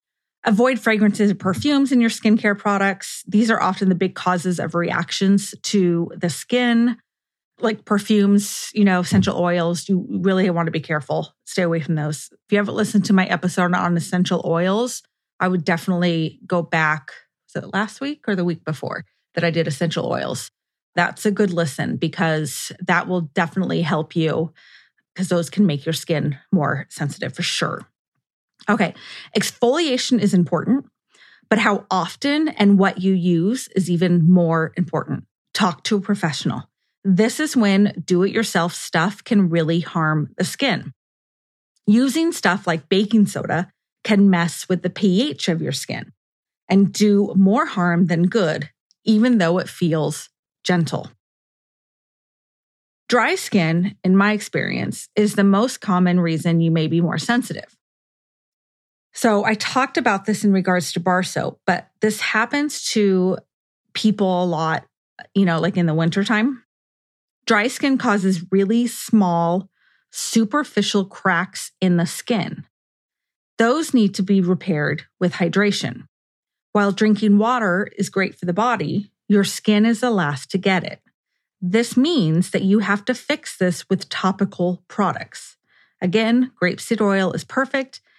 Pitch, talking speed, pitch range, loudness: 190 Hz, 155 wpm, 170-215 Hz, -20 LUFS